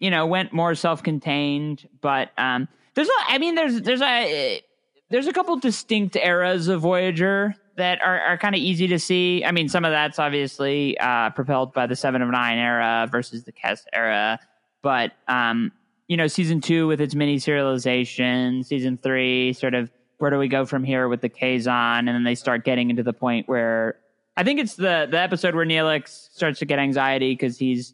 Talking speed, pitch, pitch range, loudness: 200 wpm, 145 Hz, 125-180 Hz, -22 LUFS